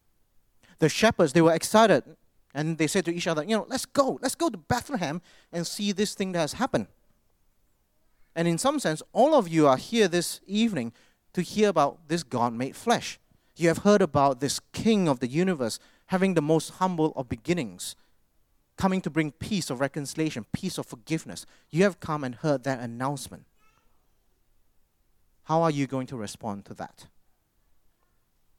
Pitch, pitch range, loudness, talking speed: 160 Hz, 135-195 Hz, -26 LUFS, 175 wpm